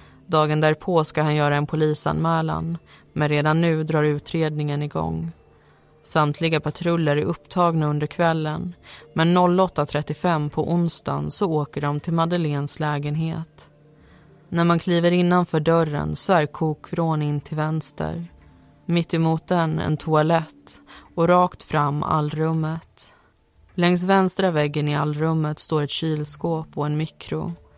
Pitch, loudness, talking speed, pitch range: 155 Hz, -22 LUFS, 125 wpm, 150-165 Hz